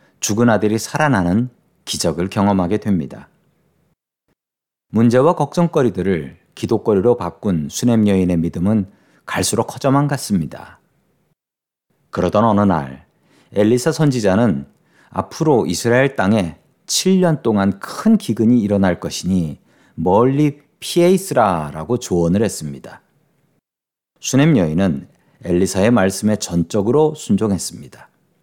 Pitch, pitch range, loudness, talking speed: 110 Hz, 95-135 Hz, -17 LUFS, 265 characters per minute